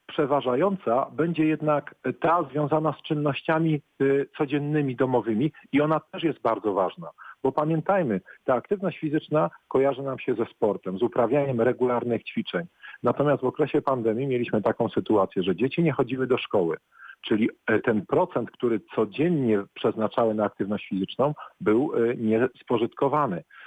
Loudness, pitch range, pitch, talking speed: -25 LUFS, 120-155 Hz, 140 Hz, 135 wpm